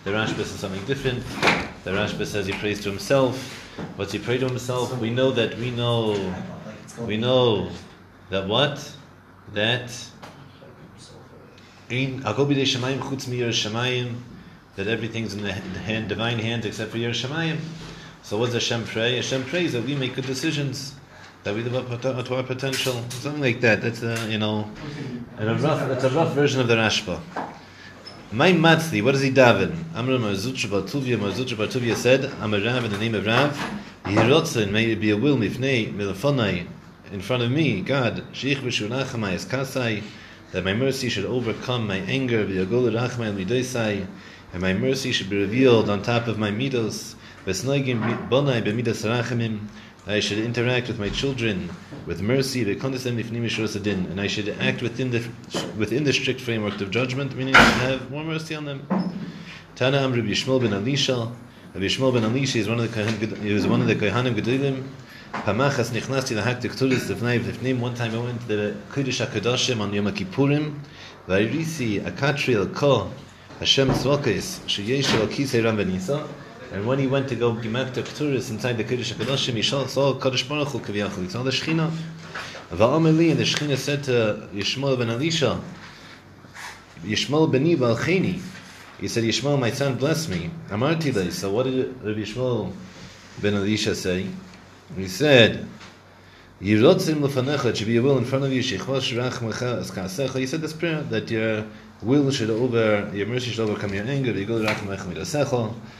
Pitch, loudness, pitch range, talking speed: 120 Hz, -23 LUFS, 105-135 Hz, 165 wpm